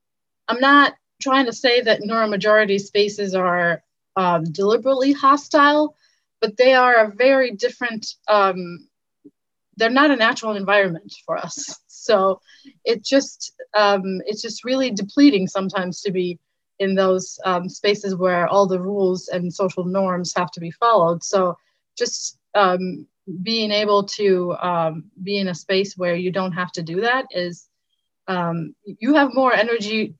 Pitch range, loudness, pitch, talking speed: 185-235 Hz, -19 LUFS, 200 Hz, 150 wpm